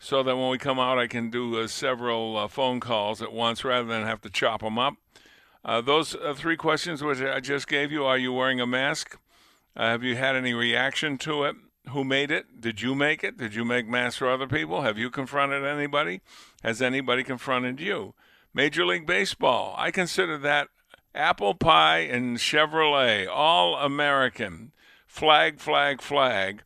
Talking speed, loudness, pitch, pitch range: 185 wpm, -25 LUFS, 130 Hz, 120-140 Hz